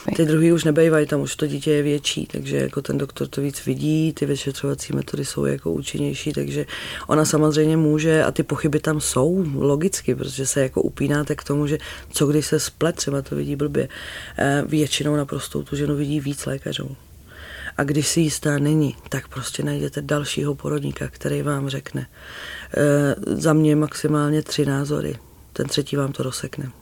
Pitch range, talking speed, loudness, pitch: 135-150 Hz, 175 wpm, -22 LUFS, 145 Hz